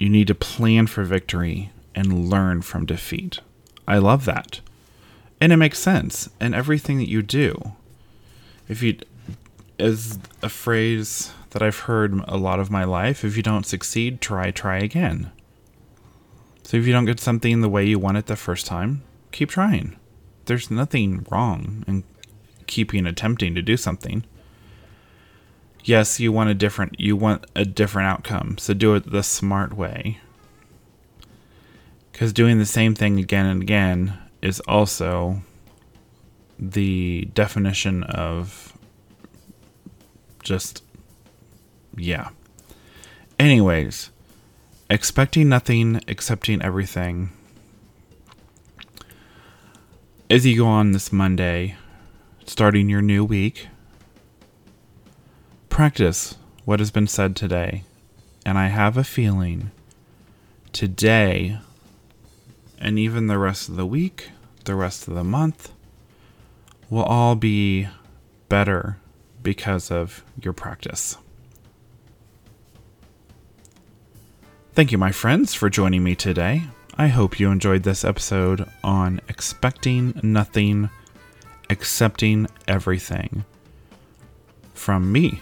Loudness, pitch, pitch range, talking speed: -21 LUFS, 105 Hz, 95-115 Hz, 115 wpm